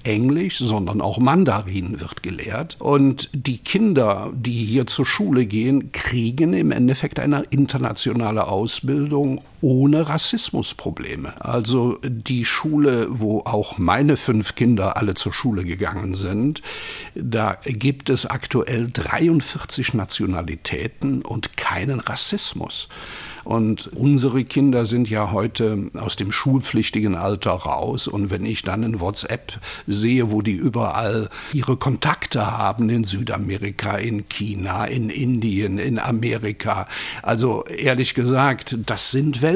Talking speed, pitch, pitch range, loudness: 125 wpm, 120 Hz, 105-135 Hz, -21 LUFS